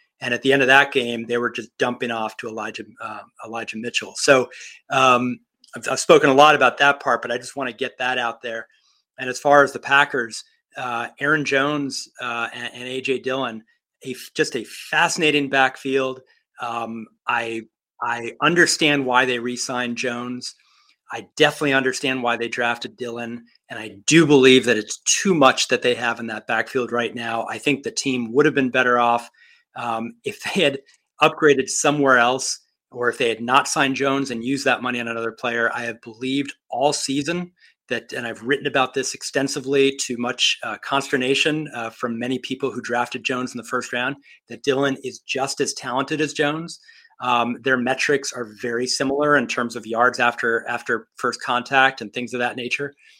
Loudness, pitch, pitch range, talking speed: -20 LUFS, 130 Hz, 120-140 Hz, 195 wpm